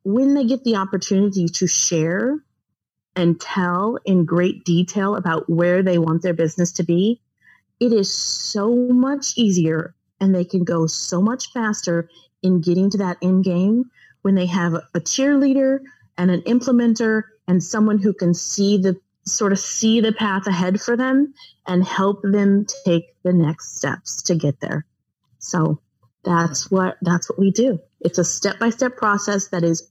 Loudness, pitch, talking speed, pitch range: -19 LUFS, 190 Hz, 170 wpm, 175-220 Hz